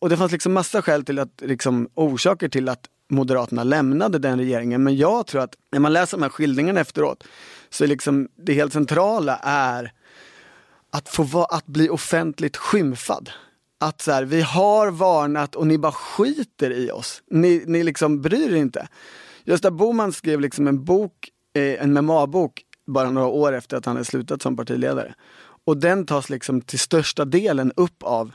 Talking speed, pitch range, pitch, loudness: 180 wpm, 135-175 Hz, 150 Hz, -21 LUFS